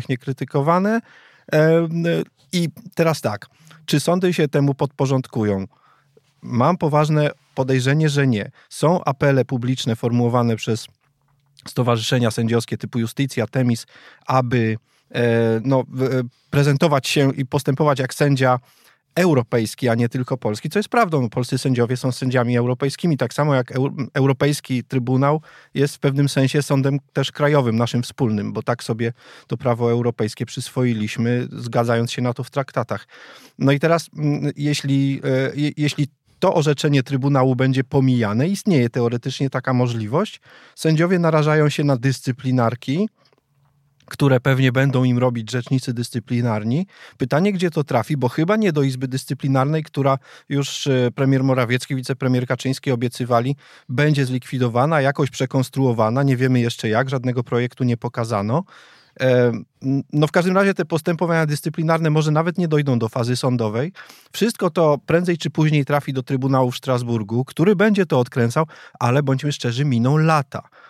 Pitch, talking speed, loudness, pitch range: 135 Hz, 135 wpm, -20 LUFS, 125-150 Hz